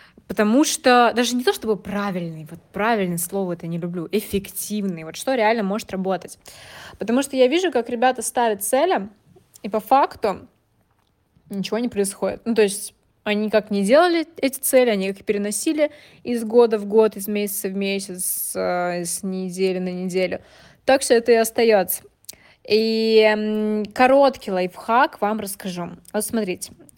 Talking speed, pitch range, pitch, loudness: 155 wpm, 195-240 Hz, 210 Hz, -21 LUFS